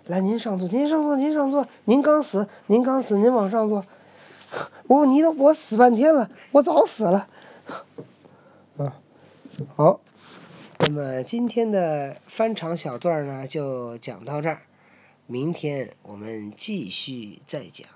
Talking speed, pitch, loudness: 195 characters per minute, 200 Hz, -22 LUFS